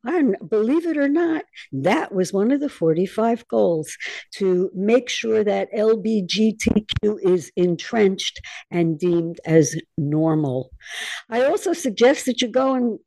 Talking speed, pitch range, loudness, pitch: 140 wpm, 175-250 Hz, -21 LUFS, 210 Hz